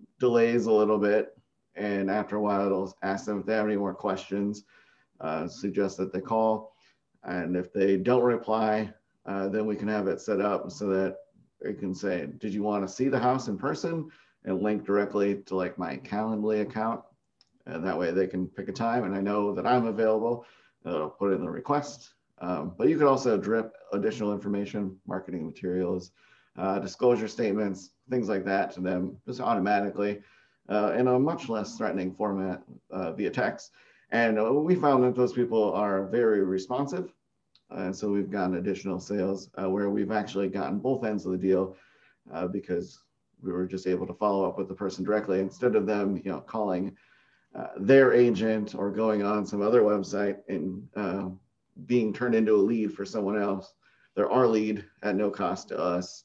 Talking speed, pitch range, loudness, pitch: 190 wpm, 95-110 Hz, -28 LUFS, 100 Hz